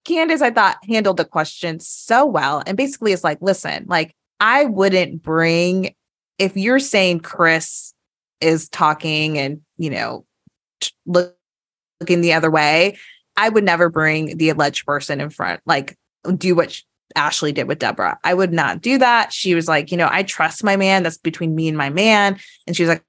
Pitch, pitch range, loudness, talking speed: 170 Hz, 160-195 Hz, -17 LUFS, 185 wpm